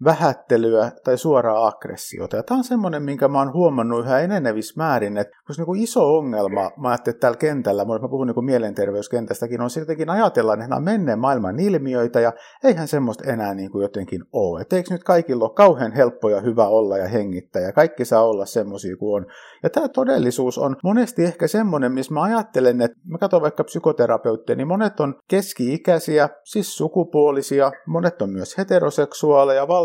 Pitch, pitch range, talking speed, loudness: 135 Hz, 115-170 Hz, 175 wpm, -20 LUFS